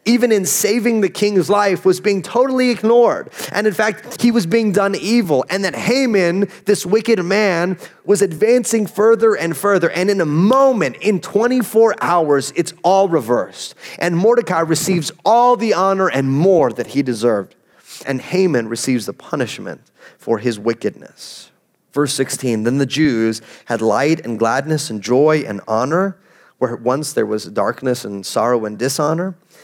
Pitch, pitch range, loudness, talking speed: 180 Hz, 135-210 Hz, -16 LUFS, 165 wpm